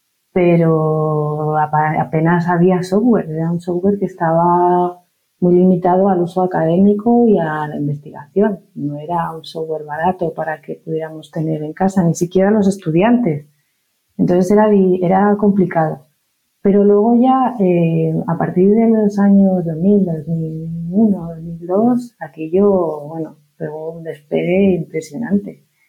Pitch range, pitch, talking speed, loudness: 160-195 Hz, 175 Hz, 125 wpm, -15 LUFS